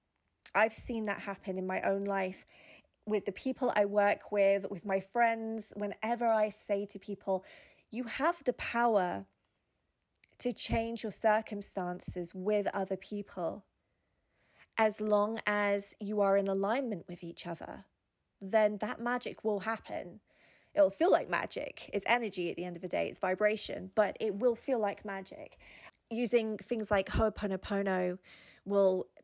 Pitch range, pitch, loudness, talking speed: 190-220 Hz, 205 Hz, -33 LUFS, 150 wpm